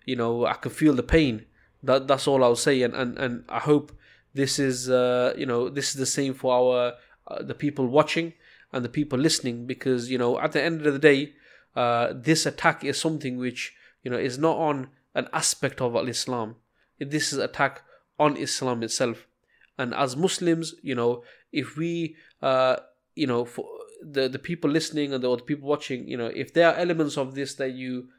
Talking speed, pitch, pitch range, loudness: 205 wpm, 135 Hz, 125-150 Hz, -25 LUFS